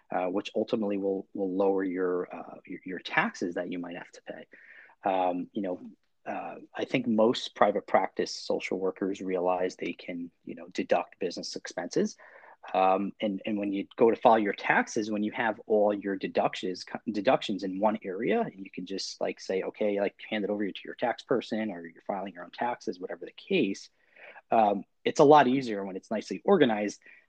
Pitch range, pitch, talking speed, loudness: 95-105 Hz, 100 Hz, 195 wpm, -29 LUFS